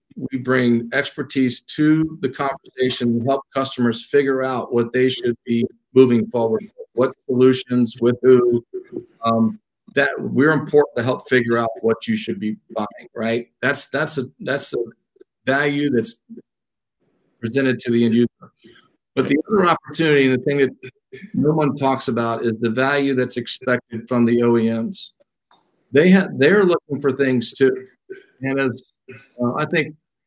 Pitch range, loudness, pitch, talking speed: 120-145 Hz, -19 LUFS, 130 Hz, 160 wpm